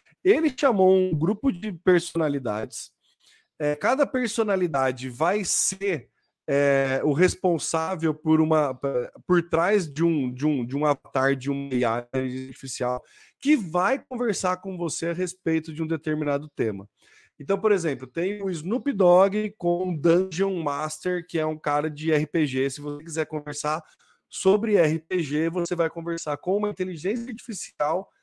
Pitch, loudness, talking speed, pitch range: 165 Hz, -25 LUFS, 150 wpm, 150-190 Hz